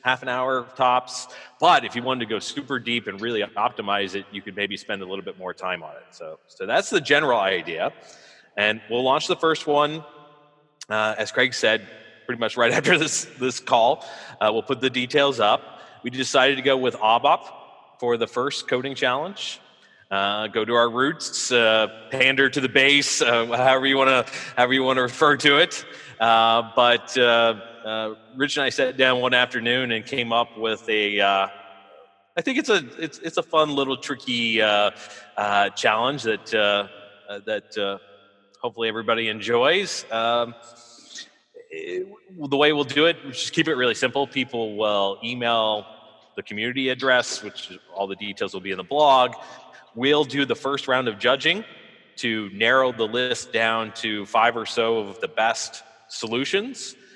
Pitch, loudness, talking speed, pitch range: 120 Hz, -22 LUFS, 180 wpm, 110-135 Hz